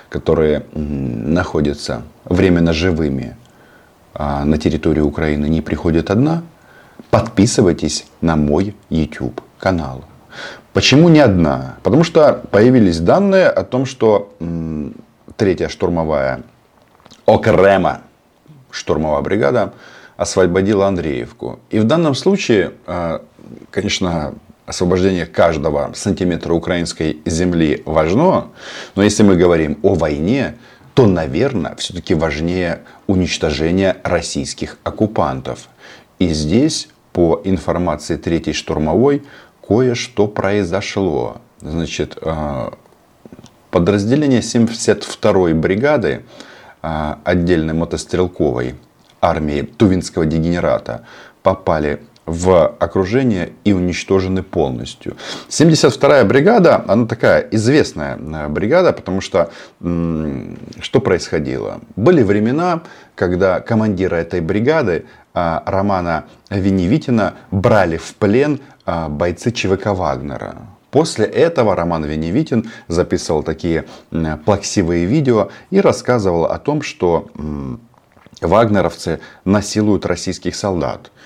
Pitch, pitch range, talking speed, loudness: 90 Hz, 80-100 Hz, 90 wpm, -16 LUFS